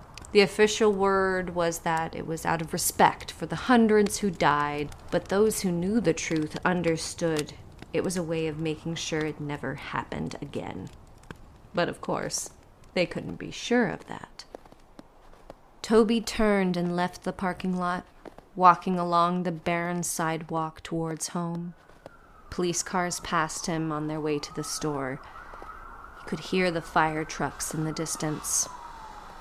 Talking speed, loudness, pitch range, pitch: 155 wpm, -27 LUFS, 160-185 Hz, 170 Hz